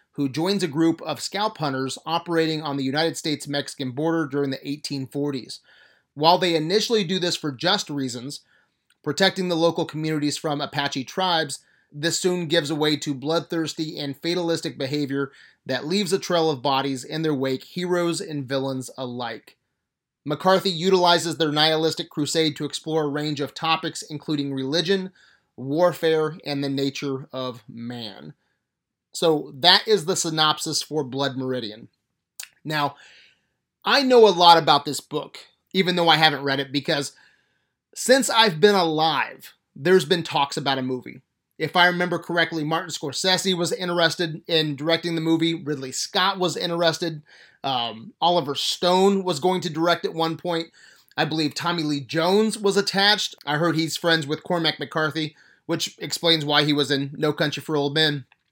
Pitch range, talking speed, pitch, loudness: 145-175 Hz, 160 wpm, 160 Hz, -22 LUFS